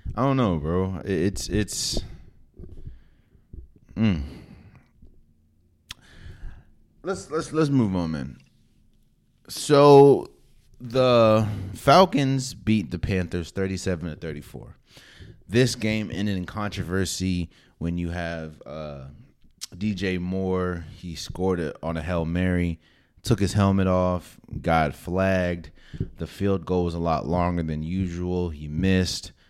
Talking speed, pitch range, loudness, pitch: 120 wpm, 85-105 Hz, -24 LUFS, 90 Hz